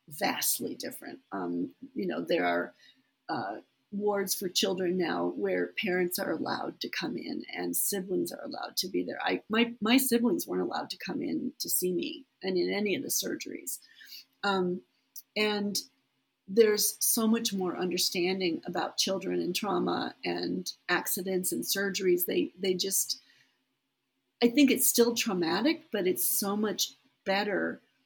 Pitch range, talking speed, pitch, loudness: 180-225 Hz, 155 wpm, 195 Hz, -30 LUFS